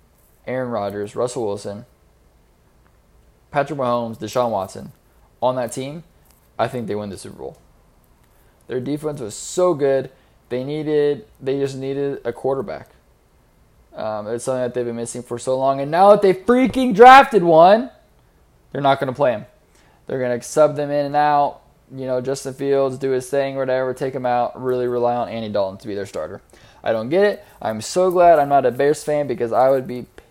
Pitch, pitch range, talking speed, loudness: 130 Hz, 120-145 Hz, 190 wpm, -19 LUFS